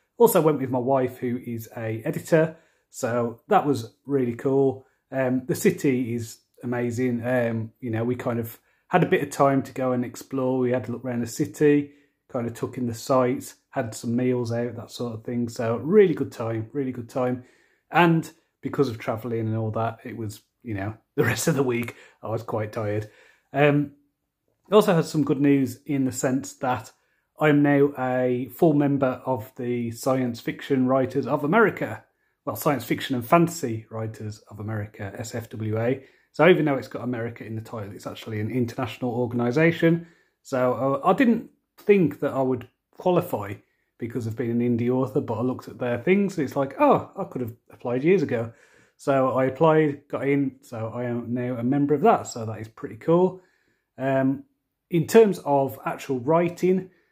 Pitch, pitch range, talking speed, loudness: 130 Hz, 120-145 Hz, 190 wpm, -24 LUFS